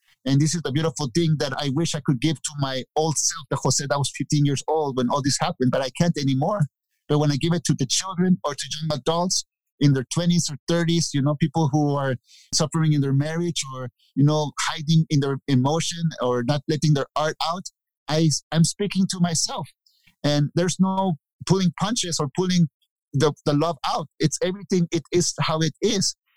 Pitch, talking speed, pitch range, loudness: 155 Hz, 210 wpm, 145-170 Hz, -23 LUFS